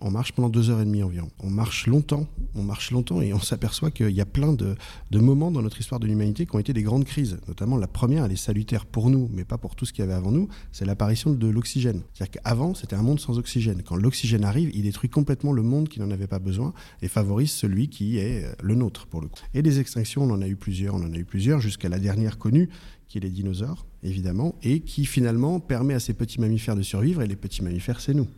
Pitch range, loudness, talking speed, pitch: 100-135 Hz, -25 LUFS, 265 wpm, 115 Hz